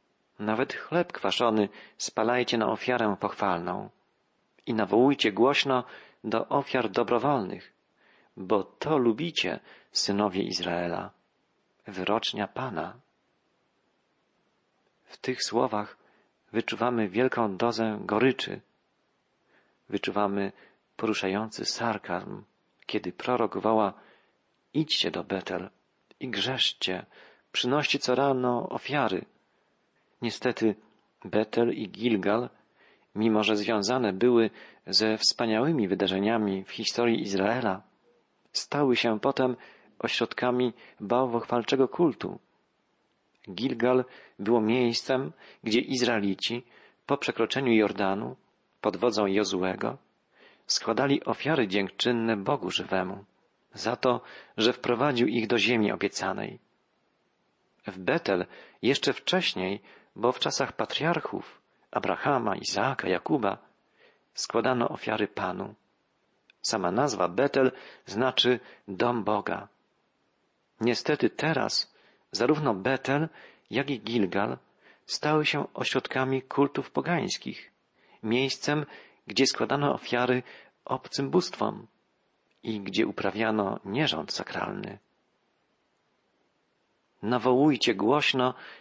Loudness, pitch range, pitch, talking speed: -28 LUFS, 105-130 Hz, 115 Hz, 90 wpm